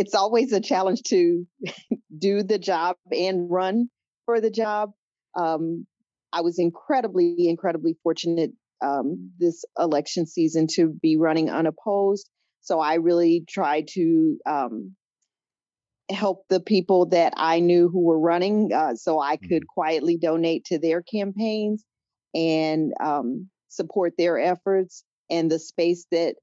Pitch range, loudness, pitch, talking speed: 165-200 Hz, -23 LUFS, 175 Hz, 135 wpm